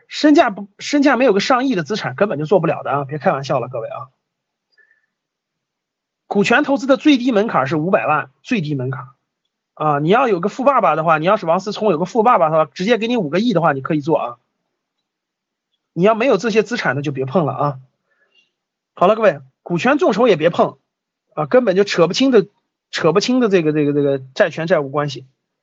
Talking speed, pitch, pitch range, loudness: 315 characters per minute, 190 Hz, 150-235 Hz, -16 LUFS